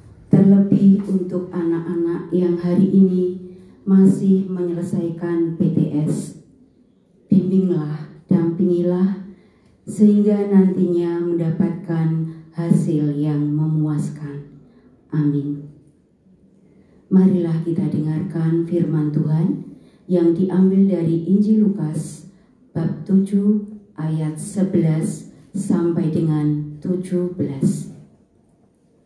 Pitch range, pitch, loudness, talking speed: 160-190 Hz, 175 Hz, -19 LUFS, 70 wpm